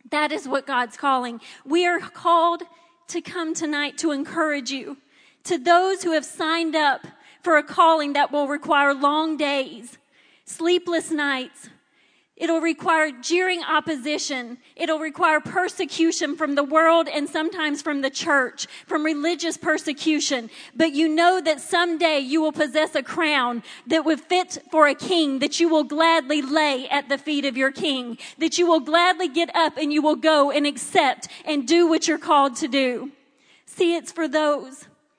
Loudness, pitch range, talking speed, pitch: -21 LUFS, 285-330 Hz, 165 wpm, 310 Hz